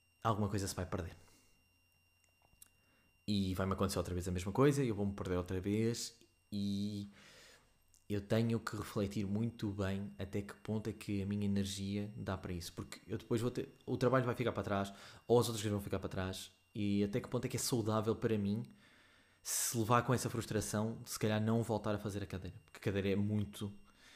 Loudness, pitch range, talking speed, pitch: -38 LUFS, 95-115 Hz, 210 wpm, 100 Hz